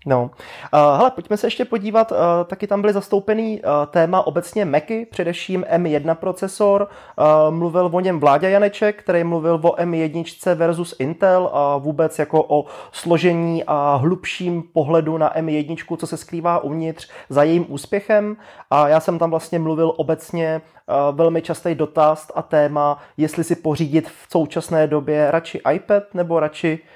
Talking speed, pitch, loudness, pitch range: 145 wpm, 165 Hz, -19 LUFS, 155-180 Hz